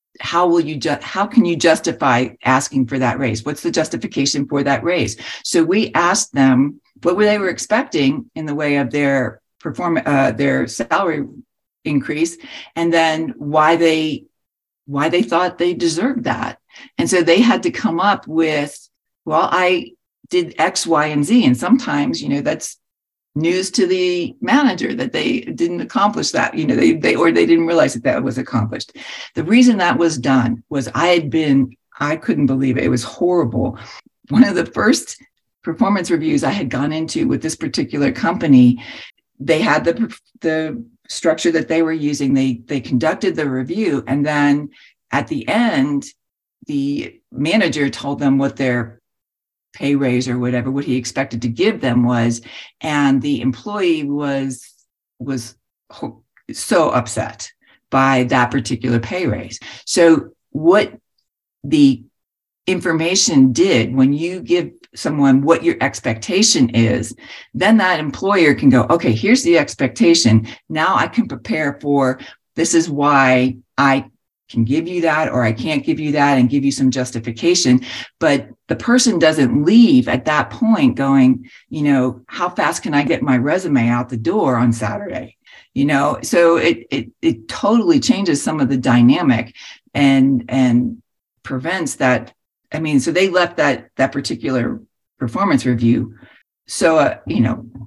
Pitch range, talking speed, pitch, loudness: 130-180 Hz, 160 wpm, 145 Hz, -16 LUFS